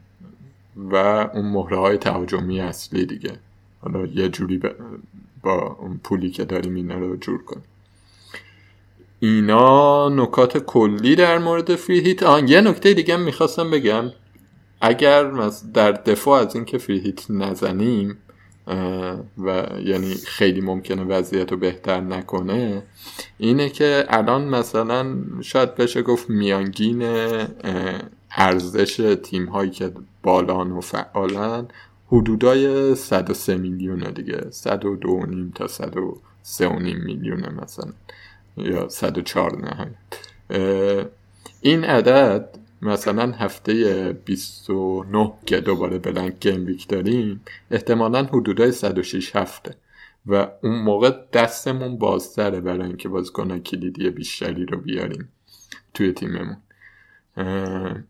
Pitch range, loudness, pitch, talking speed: 95-120 Hz, -20 LUFS, 100 Hz, 105 wpm